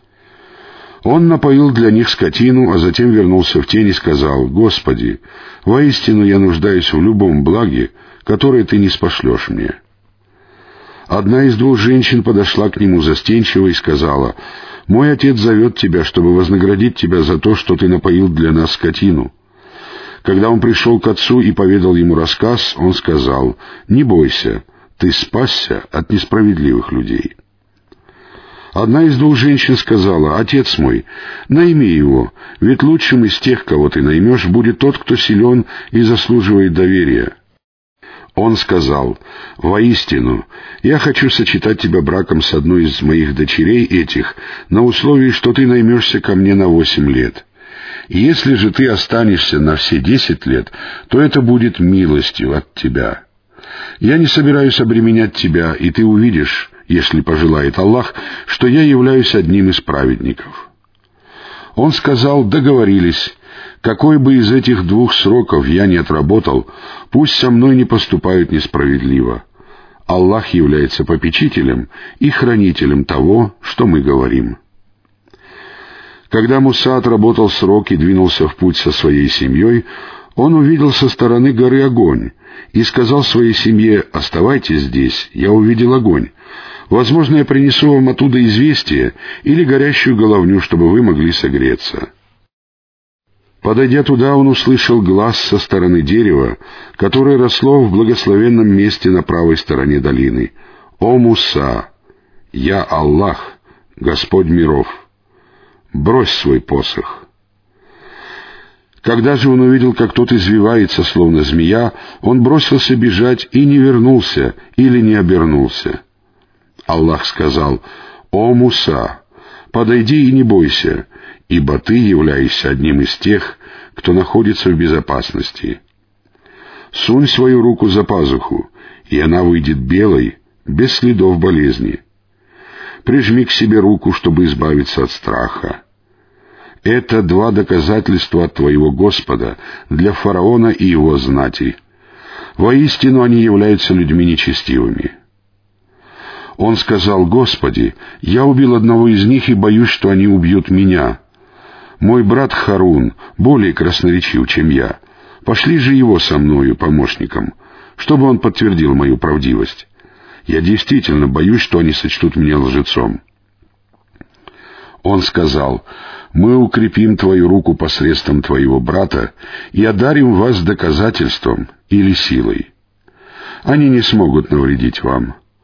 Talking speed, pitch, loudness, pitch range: 125 wpm, 105 Hz, -11 LUFS, 90-125 Hz